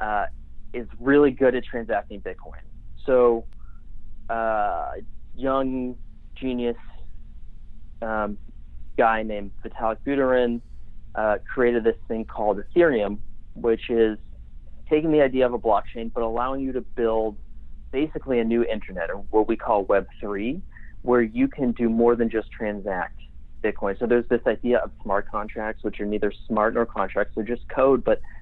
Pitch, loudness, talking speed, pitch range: 115 Hz, -24 LUFS, 150 wpm, 105-120 Hz